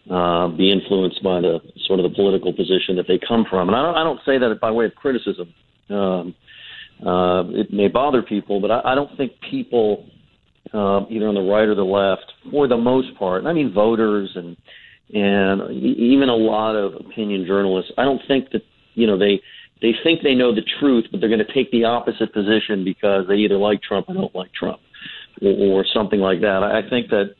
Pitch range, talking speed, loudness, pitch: 95-115 Hz, 220 wpm, -19 LUFS, 100 Hz